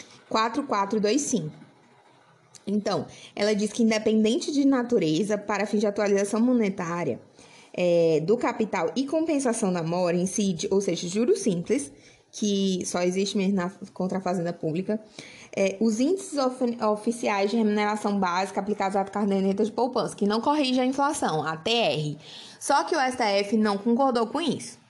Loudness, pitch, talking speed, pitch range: -25 LUFS, 210 Hz, 150 wpm, 195-235 Hz